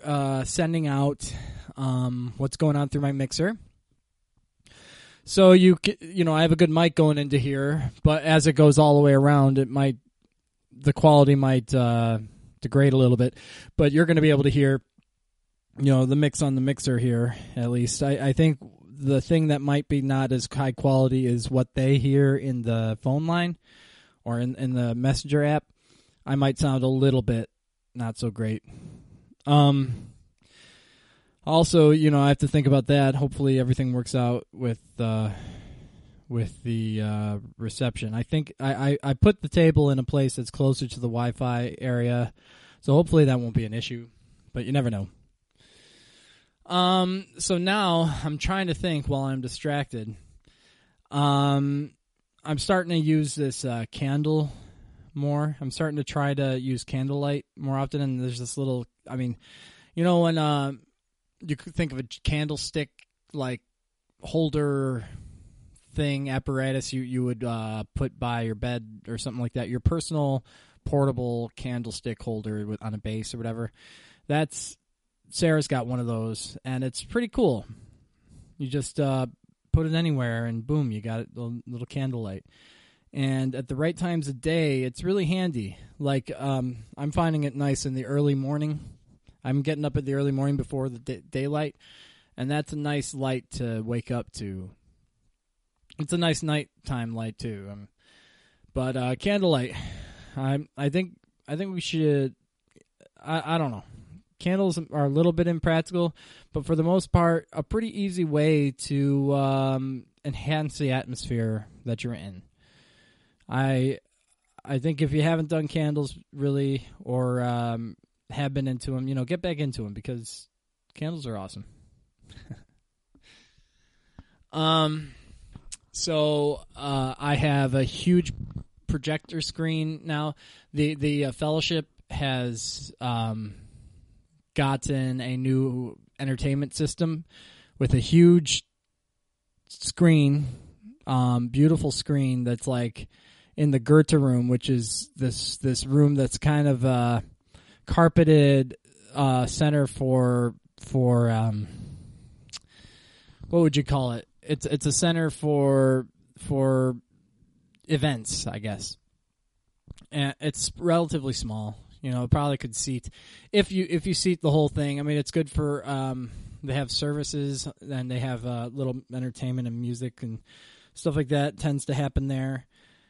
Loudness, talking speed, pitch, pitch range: -25 LUFS, 155 wpm, 135 Hz, 120-150 Hz